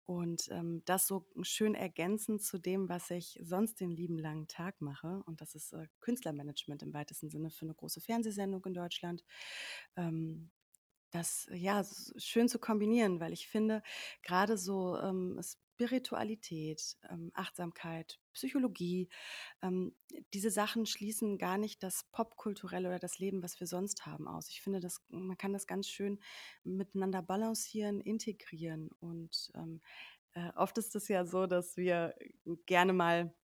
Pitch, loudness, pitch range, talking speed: 185 Hz, -38 LUFS, 170-210 Hz, 155 wpm